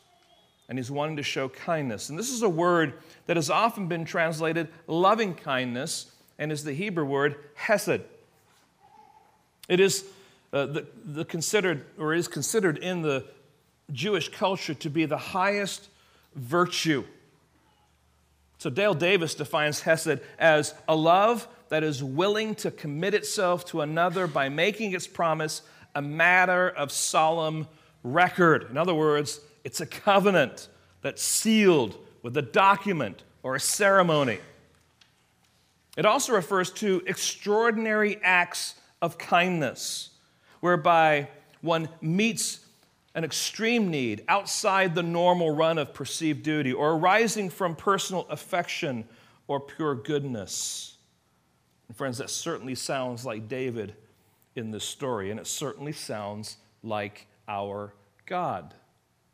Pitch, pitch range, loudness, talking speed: 160 Hz, 140-185 Hz, -26 LUFS, 130 wpm